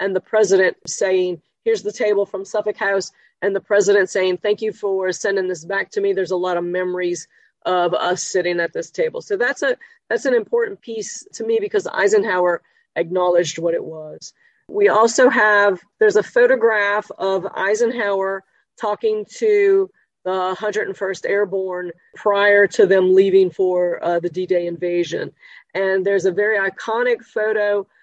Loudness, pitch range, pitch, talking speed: -19 LUFS, 185-225 Hz, 200 Hz, 165 wpm